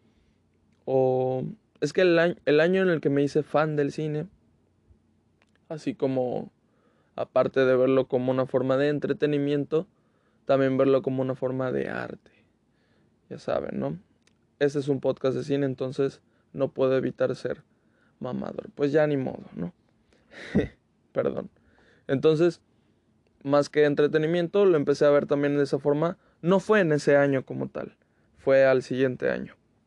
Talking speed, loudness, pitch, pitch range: 155 wpm, -25 LUFS, 135 Hz, 130-150 Hz